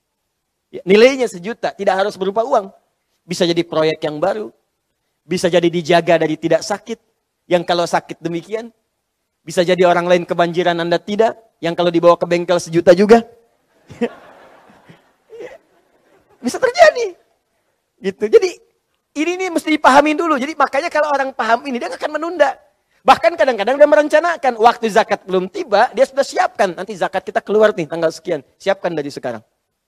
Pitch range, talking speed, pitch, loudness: 175-275 Hz, 150 wpm, 215 Hz, -16 LUFS